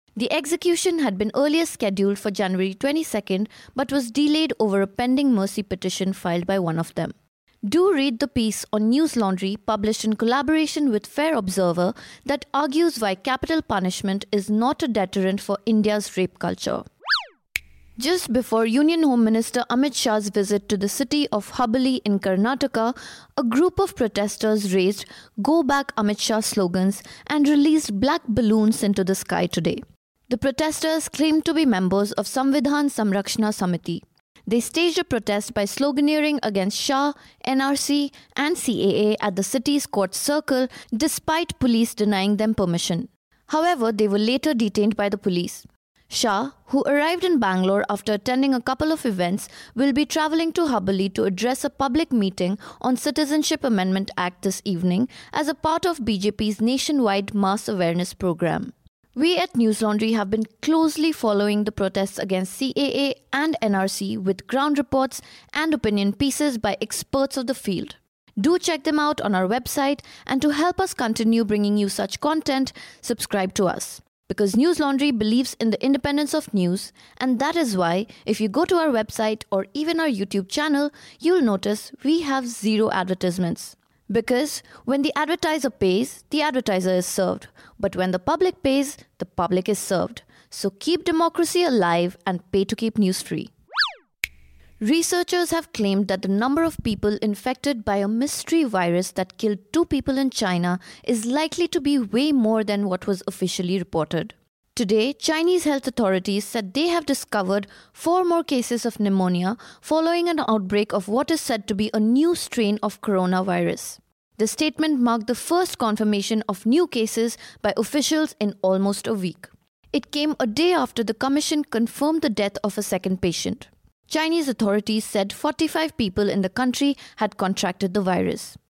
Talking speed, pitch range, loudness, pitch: 165 wpm, 200-290 Hz, -22 LUFS, 230 Hz